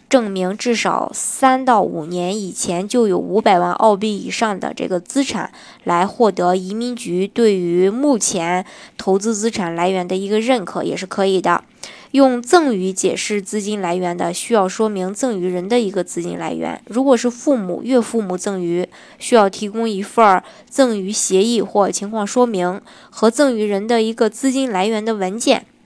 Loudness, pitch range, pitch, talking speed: -17 LUFS, 185-235 Hz, 210 Hz, 260 characters per minute